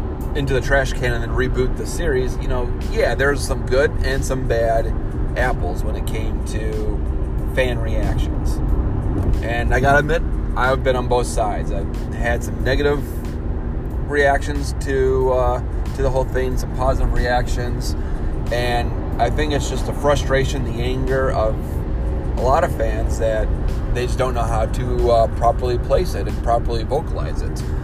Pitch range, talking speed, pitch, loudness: 80-125 Hz, 165 wpm, 115 Hz, -21 LUFS